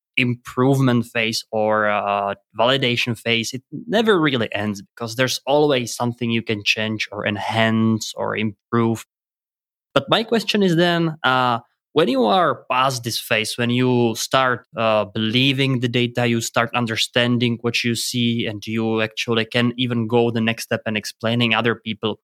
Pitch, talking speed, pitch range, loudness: 115 Hz, 160 wpm, 110-125 Hz, -20 LUFS